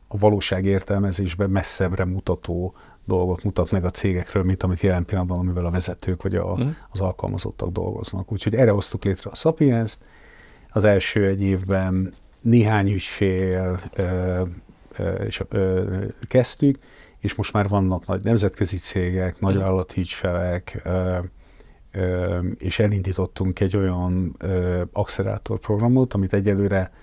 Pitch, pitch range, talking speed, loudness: 95 Hz, 90-105 Hz, 120 wpm, -23 LUFS